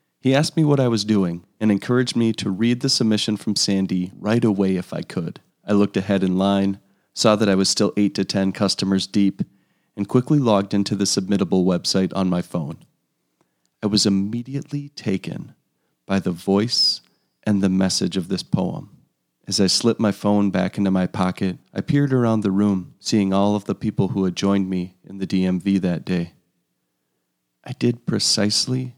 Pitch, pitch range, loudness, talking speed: 100 Hz, 95-110 Hz, -20 LUFS, 185 wpm